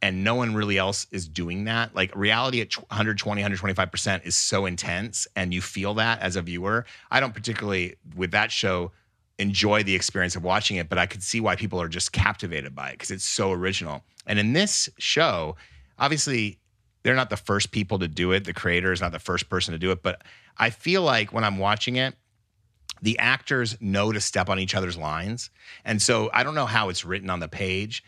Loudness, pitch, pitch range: -24 LUFS, 100 Hz, 90-110 Hz